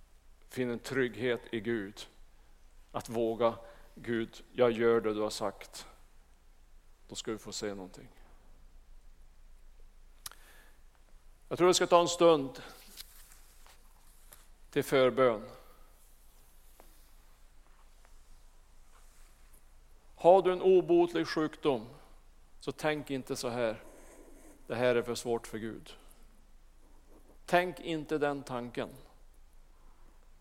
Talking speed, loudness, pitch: 100 wpm, -31 LUFS, 115 Hz